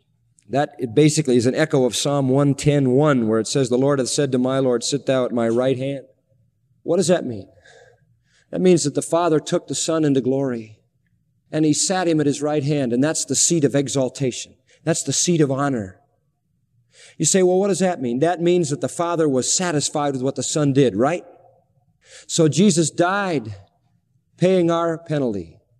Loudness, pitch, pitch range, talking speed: -19 LUFS, 140 Hz, 130-160 Hz, 195 wpm